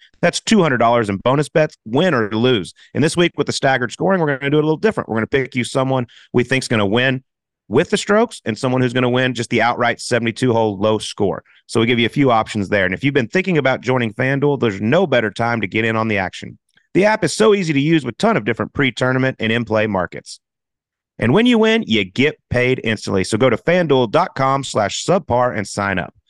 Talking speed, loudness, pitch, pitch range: 245 wpm, -17 LUFS, 125 Hz, 110-145 Hz